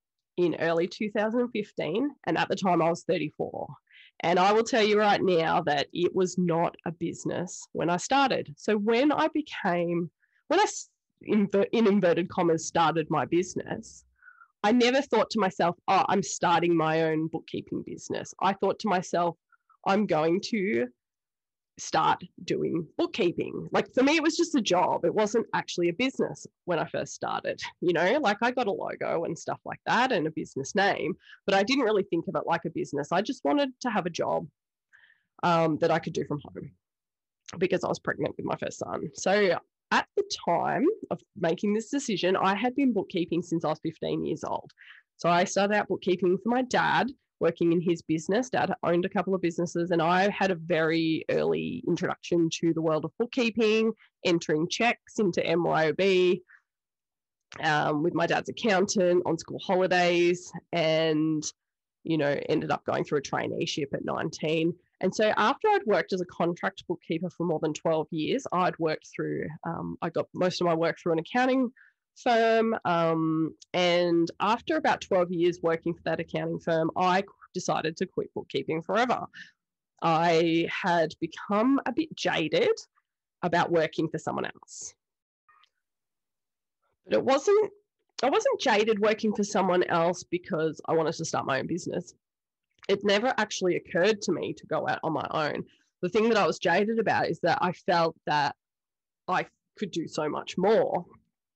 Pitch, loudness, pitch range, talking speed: 180 Hz, -27 LUFS, 165-220 Hz, 175 wpm